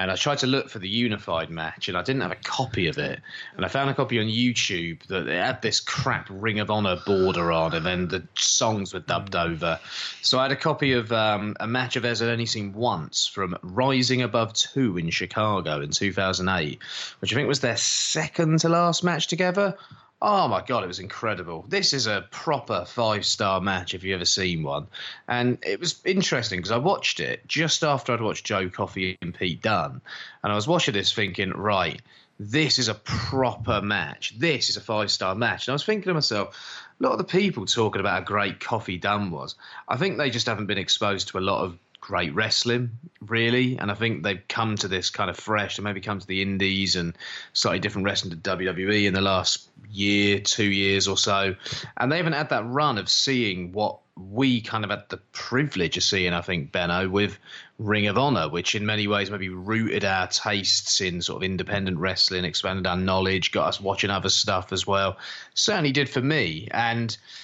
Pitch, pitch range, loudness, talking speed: 105 Hz, 95-125 Hz, -24 LUFS, 215 wpm